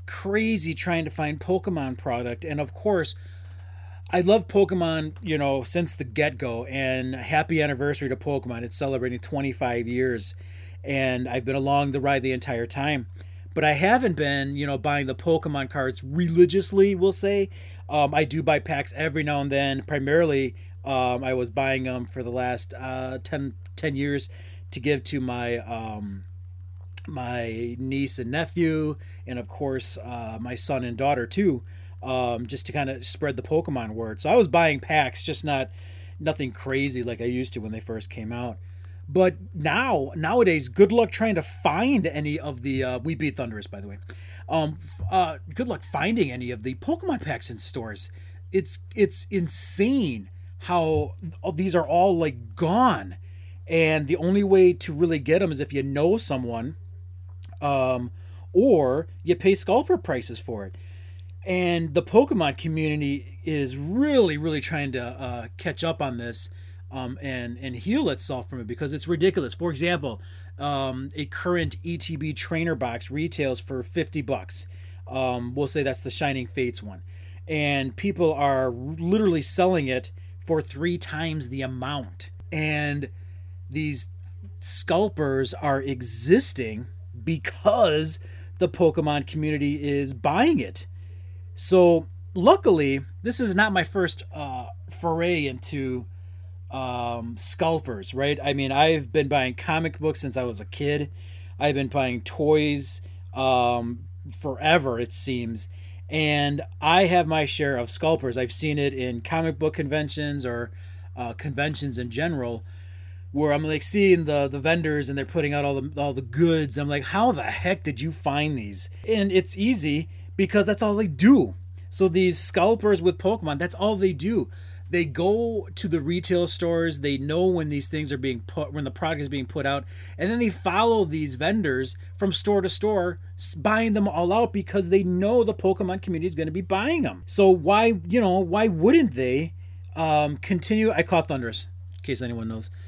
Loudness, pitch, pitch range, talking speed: -24 LUFS, 135 Hz, 100-165 Hz, 170 wpm